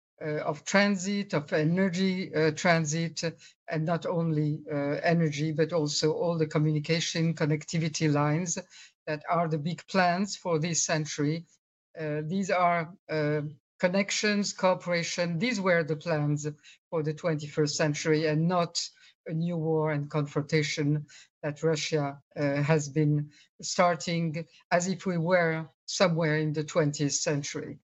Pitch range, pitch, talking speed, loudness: 155-175 Hz, 160 Hz, 135 wpm, -28 LUFS